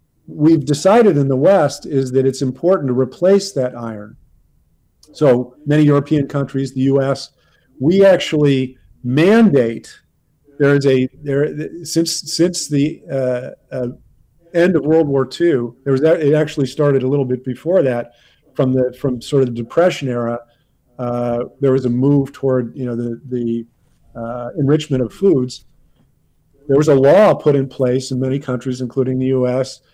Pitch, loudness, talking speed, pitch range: 135 Hz, -16 LUFS, 165 wpm, 125-150 Hz